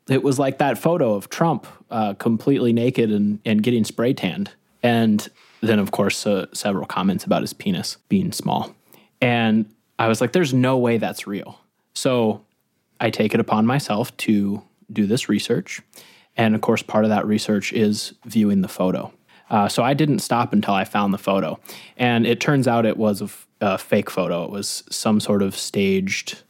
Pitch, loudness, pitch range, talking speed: 115 Hz, -21 LUFS, 105-125 Hz, 190 wpm